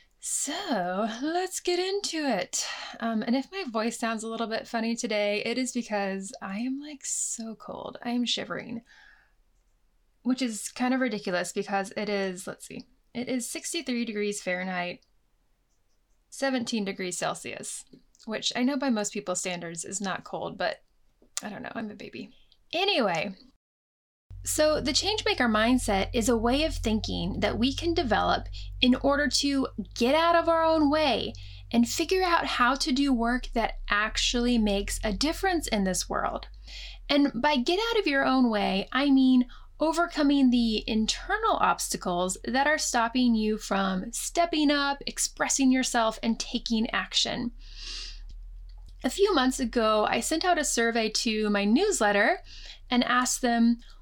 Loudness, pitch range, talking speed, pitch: -27 LUFS, 210-280 Hz, 155 wpm, 240 Hz